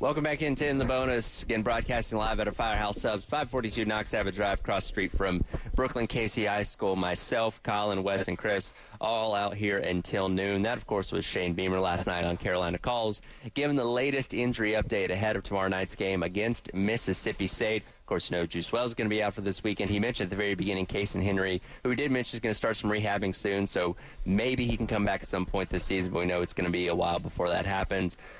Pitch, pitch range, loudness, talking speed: 105 Hz, 95-115 Hz, -30 LUFS, 245 wpm